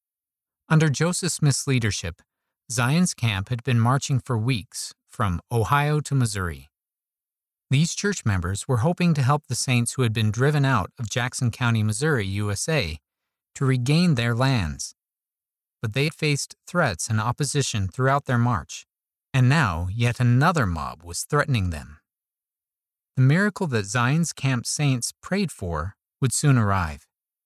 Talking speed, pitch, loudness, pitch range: 145 wpm, 125 Hz, -23 LUFS, 105-145 Hz